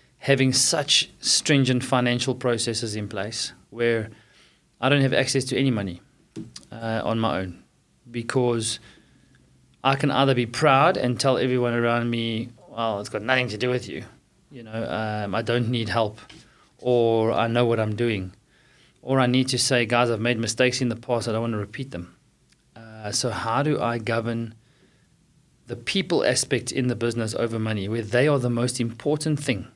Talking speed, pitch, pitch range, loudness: 180 wpm, 120 Hz, 115-130 Hz, -23 LUFS